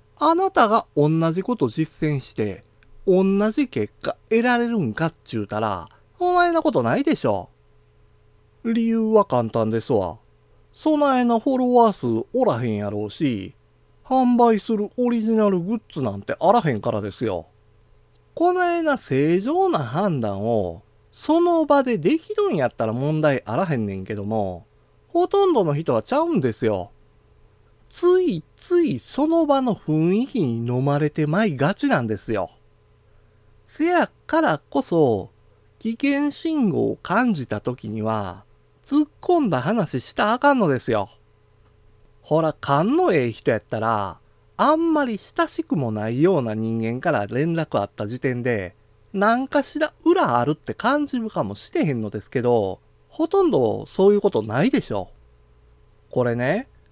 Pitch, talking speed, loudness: 155 Hz, 285 characters per minute, -21 LUFS